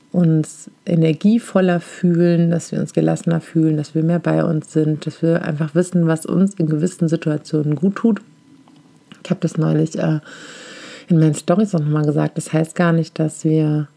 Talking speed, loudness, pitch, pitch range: 175 wpm, -18 LUFS, 165 Hz, 155-180 Hz